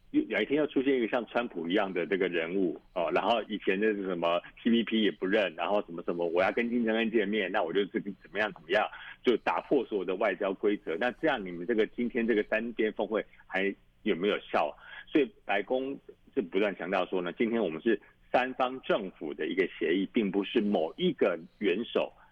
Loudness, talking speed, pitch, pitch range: -30 LUFS, 325 characters per minute, 120 Hz, 105-135 Hz